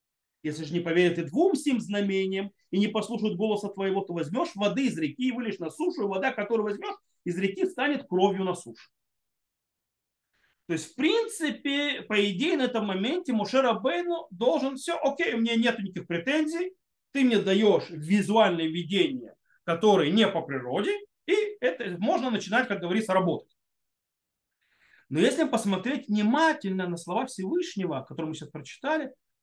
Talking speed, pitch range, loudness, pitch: 160 wpm, 190-285 Hz, -27 LUFS, 215 Hz